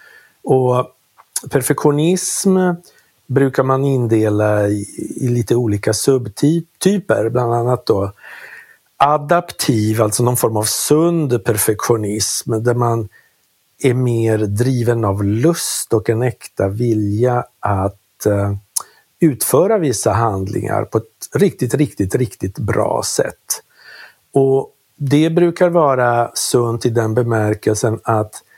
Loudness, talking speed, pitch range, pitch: -16 LUFS, 105 wpm, 110-140 Hz, 120 Hz